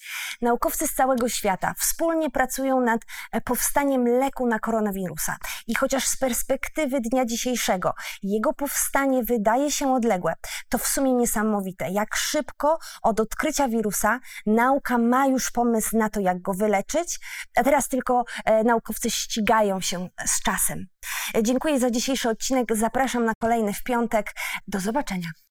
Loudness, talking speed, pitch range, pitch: -24 LUFS, 140 wpm, 220-270 Hz, 240 Hz